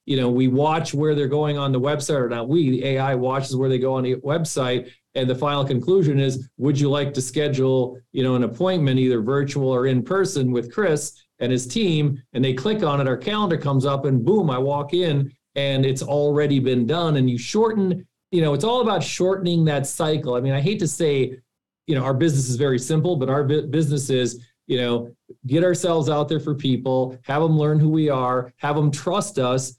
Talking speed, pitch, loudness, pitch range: 225 wpm, 140 Hz, -21 LUFS, 130-155 Hz